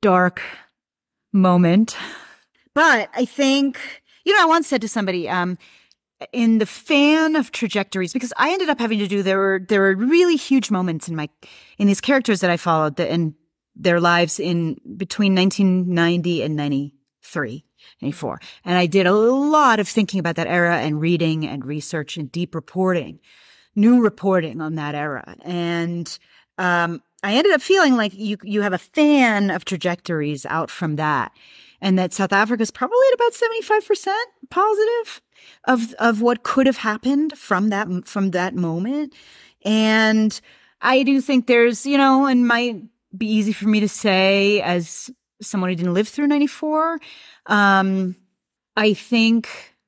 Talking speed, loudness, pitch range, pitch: 165 wpm, -19 LUFS, 175-255 Hz, 205 Hz